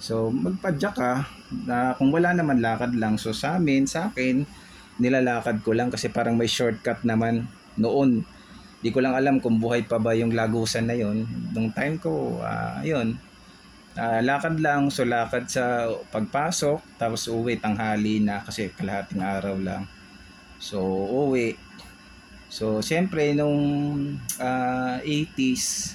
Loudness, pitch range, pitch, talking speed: -25 LUFS, 110-140 Hz, 120 Hz, 145 wpm